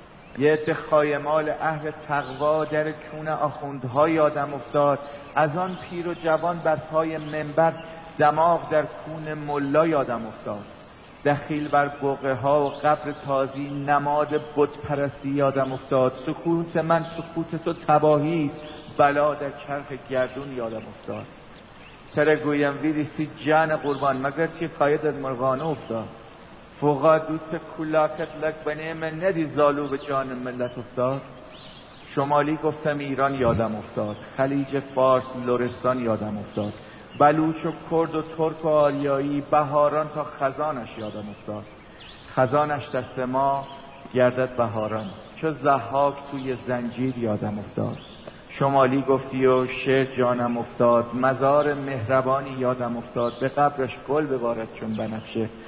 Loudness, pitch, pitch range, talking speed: -24 LUFS, 145 Hz, 130-155 Hz, 125 wpm